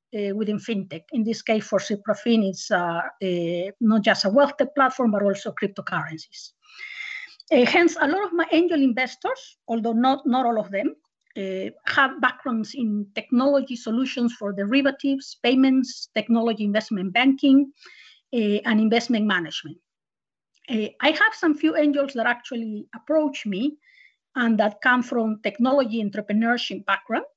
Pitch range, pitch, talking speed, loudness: 210-280 Hz, 240 Hz, 145 wpm, -23 LUFS